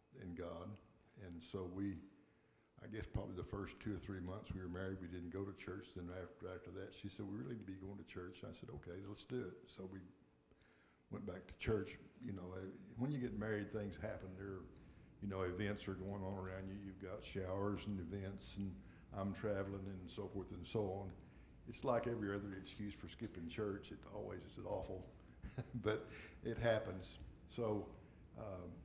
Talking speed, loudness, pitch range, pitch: 200 wpm, -47 LUFS, 90-105 Hz, 95 Hz